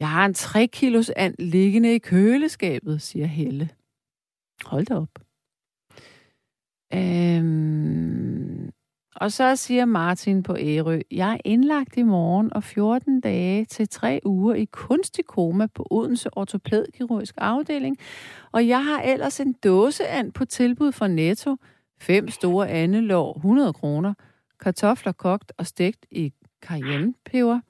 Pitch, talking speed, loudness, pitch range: 205 Hz, 130 wpm, -22 LUFS, 175-245 Hz